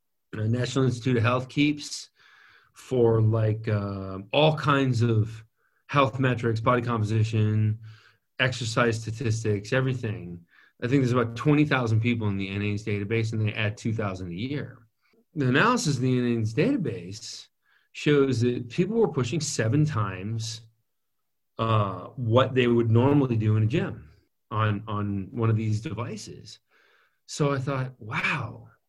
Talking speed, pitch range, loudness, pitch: 135 wpm, 110-130 Hz, -26 LUFS, 115 Hz